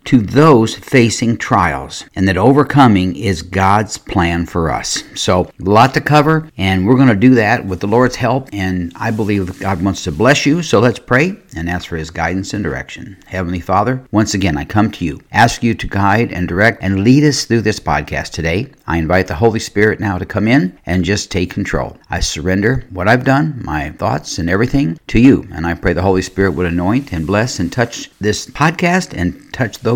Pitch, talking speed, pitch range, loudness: 100 Hz, 215 wpm, 90-125 Hz, -14 LUFS